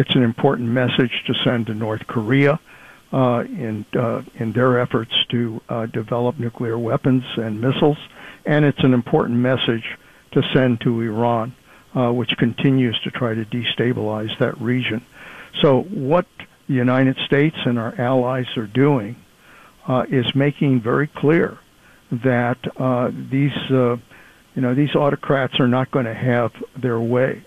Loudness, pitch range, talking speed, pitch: -20 LUFS, 120-135 Hz, 155 wpm, 125 Hz